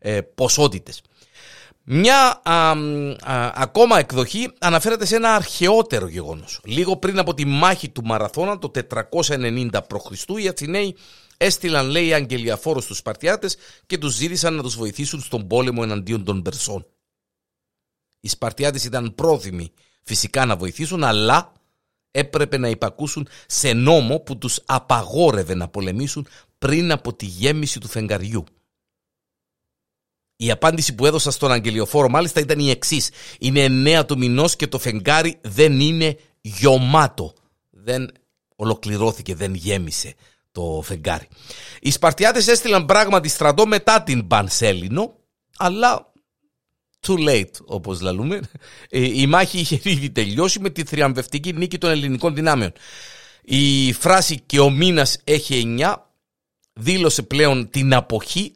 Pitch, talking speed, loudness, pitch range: 140 Hz, 130 wpm, -19 LUFS, 115-165 Hz